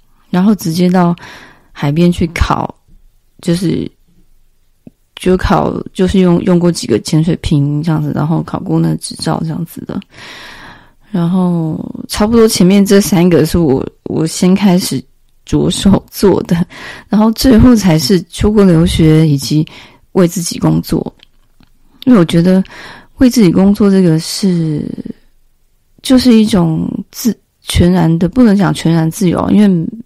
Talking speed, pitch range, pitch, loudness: 210 characters per minute, 160-200 Hz, 180 Hz, -11 LUFS